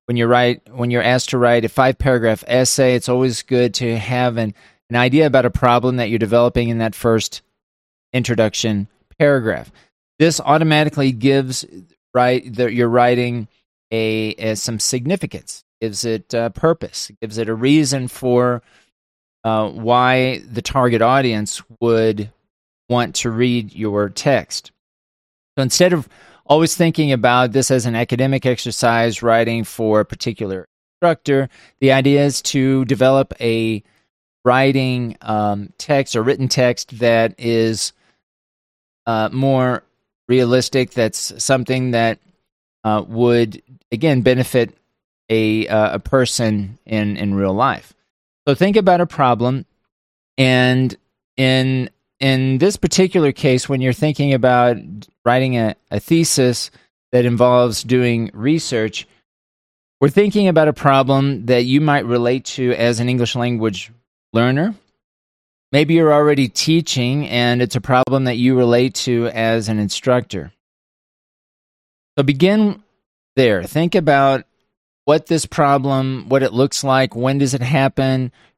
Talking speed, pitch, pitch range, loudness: 135 wpm, 125 Hz, 115-135 Hz, -17 LUFS